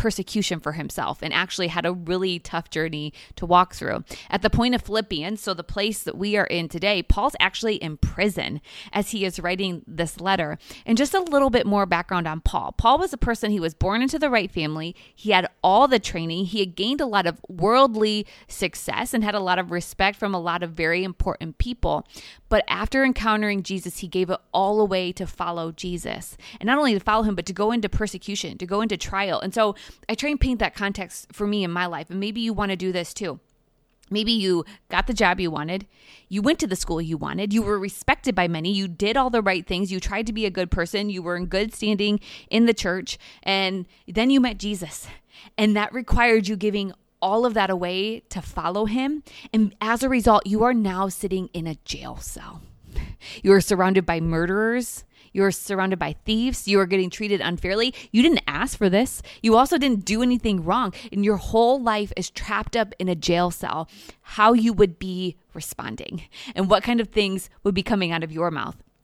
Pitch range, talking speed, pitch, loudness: 180-220 Hz, 220 wpm, 195 Hz, -23 LUFS